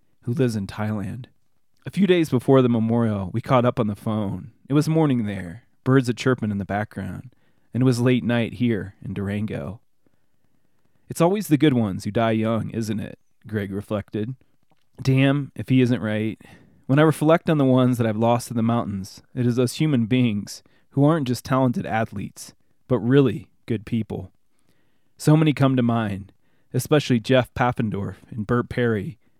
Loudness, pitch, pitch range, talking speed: -22 LUFS, 120 Hz, 110-130 Hz, 180 wpm